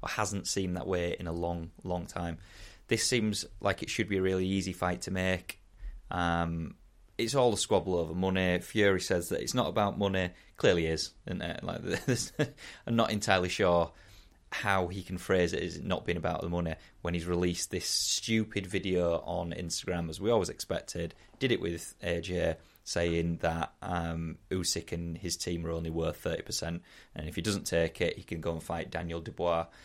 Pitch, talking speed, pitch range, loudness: 90 Hz, 195 wpm, 85-95 Hz, -32 LUFS